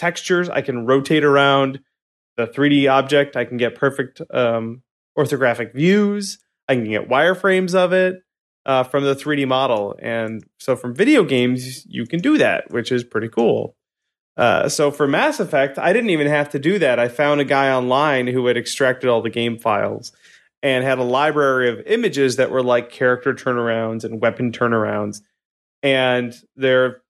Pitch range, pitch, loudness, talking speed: 120-145 Hz, 130 Hz, -18 LUFS, 175 wpm